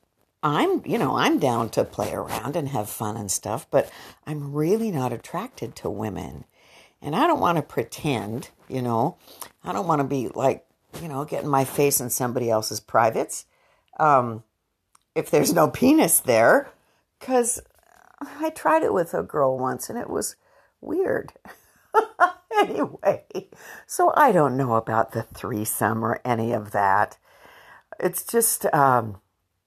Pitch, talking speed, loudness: 130 Hz, 155 wpm, -23 LUFS